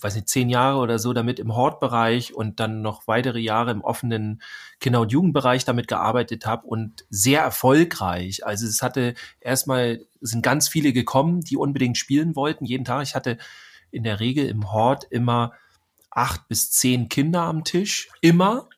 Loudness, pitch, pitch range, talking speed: -22 LUFS, 125 Hz, 115-140 Hz, 175 wpm